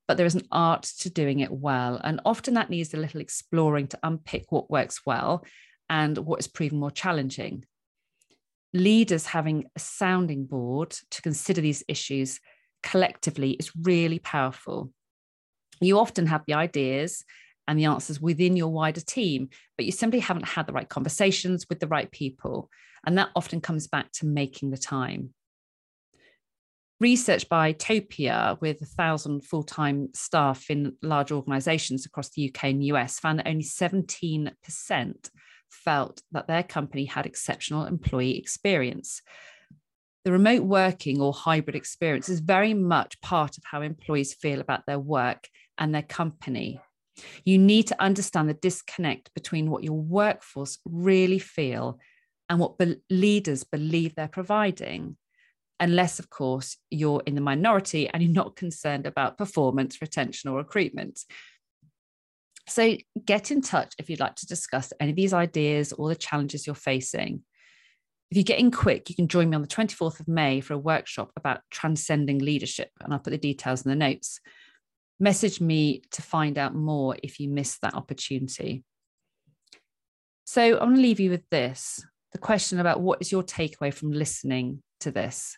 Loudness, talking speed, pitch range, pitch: -26 LUFS, 165 wpm, 140-180 Hz, 155 Hz